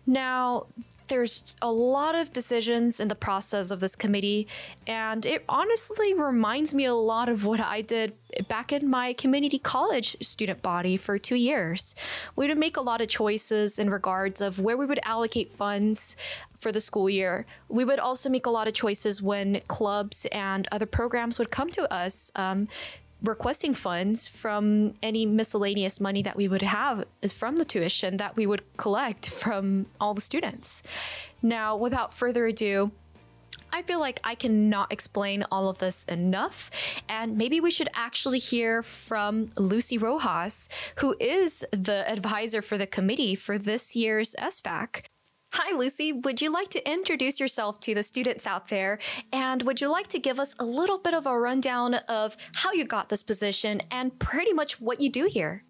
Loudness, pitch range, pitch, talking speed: -27 LUFS, 205-260 Hz, 225 Hz, 175 wpm